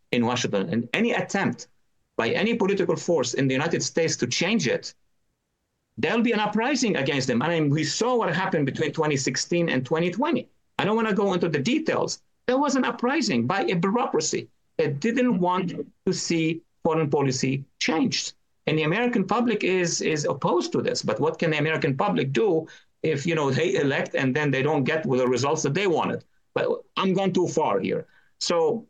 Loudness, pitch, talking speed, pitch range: -24 LUFS, 175 Hz, 195 wpm, 155-225 Hz